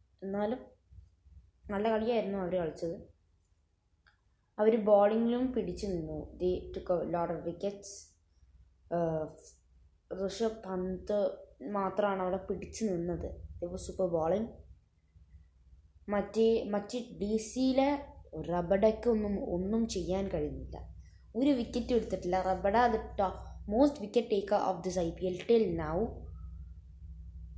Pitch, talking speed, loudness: 185 Hz, 100 wpm, -33 LUFS